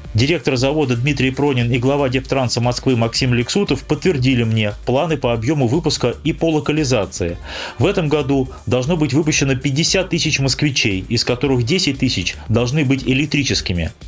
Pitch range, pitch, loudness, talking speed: 120-150 Hz, 135 Hz, -17 LUFS, 150 wpm